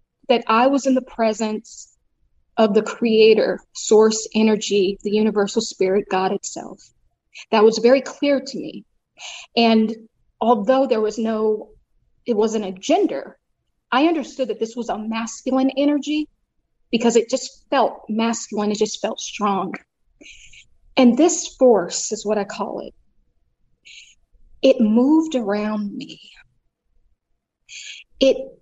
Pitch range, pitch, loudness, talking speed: 215-260 Hz, 225 Hz, -19 LUFS, 130 wpm